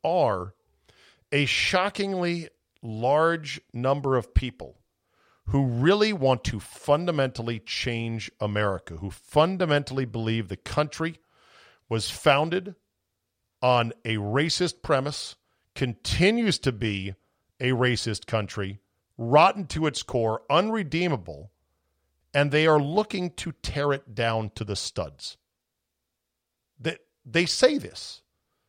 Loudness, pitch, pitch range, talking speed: -25 LUFS, 125 Hz, 105-150 Hz, 110 wpm